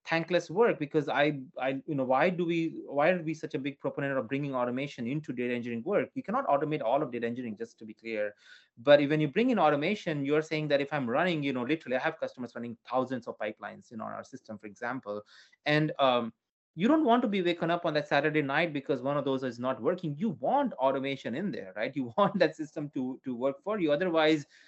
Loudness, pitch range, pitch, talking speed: -30 LUFS, 130-165 Hz, 145 Hz, 245 wpm